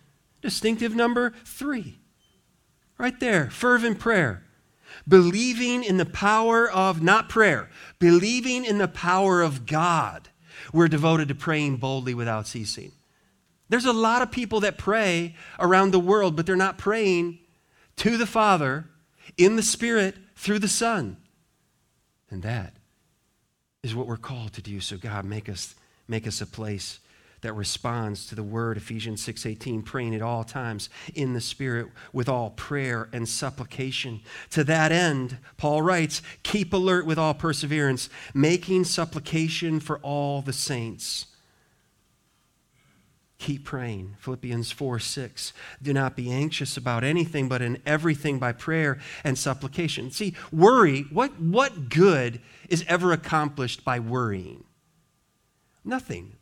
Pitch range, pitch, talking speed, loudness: 120-185 Hz, 150 Hz, 135 wpm, -24 LUFS